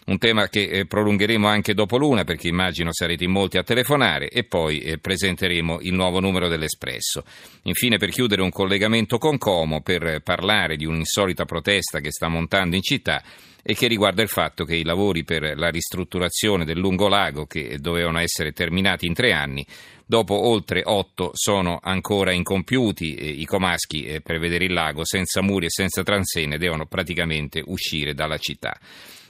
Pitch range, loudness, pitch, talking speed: 80-100 Hz, -21 LUFS, 90 Hz, 175 wpm